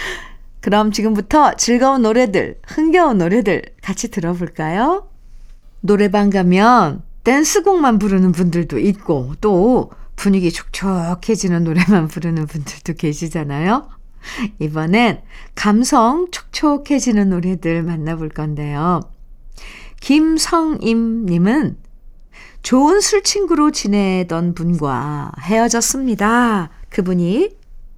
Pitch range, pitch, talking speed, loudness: 170-250 Hz, 205 Hz, 235 characters per minute, -16 LUFS